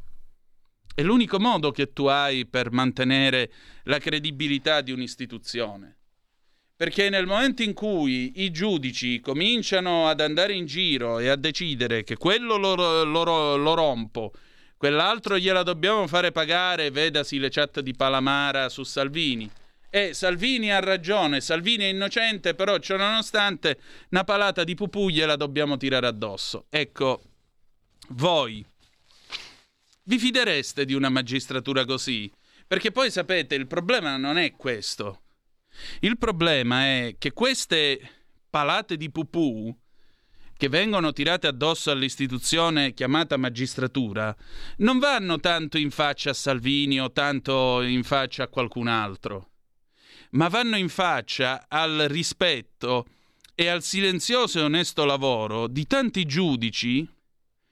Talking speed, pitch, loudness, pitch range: 130 wpm, 150 Hz, -24 LUFS, 130-185 Hz